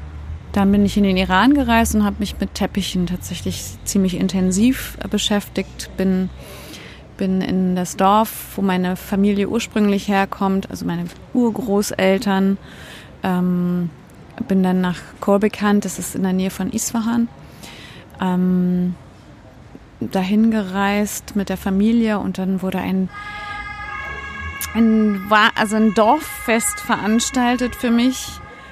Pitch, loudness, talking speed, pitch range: 200 Hz, -19 LUFS, 120 wpm, 185-220 Hz